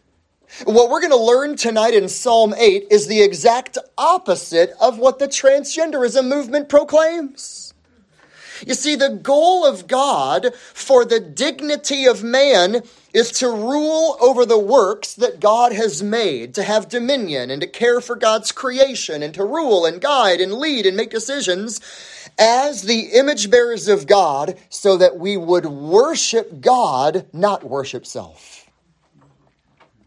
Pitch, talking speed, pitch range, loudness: 240 Hz, 150 wpm, 200-280 Hz, -16 LUFS